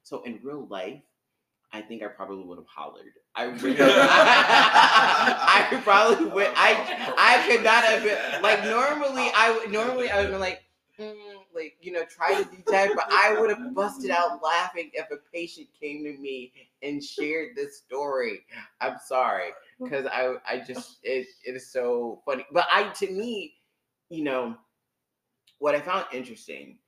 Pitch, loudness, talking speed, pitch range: 170 Hz, -22 LUFS, 175 wpm, 130-215 Hz